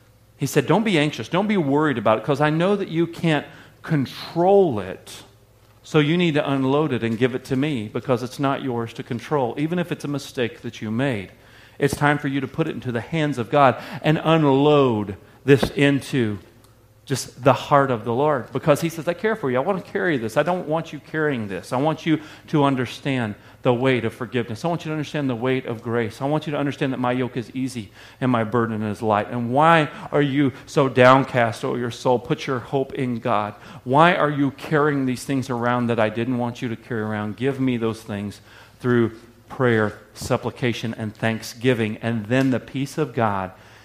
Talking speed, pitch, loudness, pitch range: 220 wpm, 130 Hz, -22 LUFS, 115-145 Hz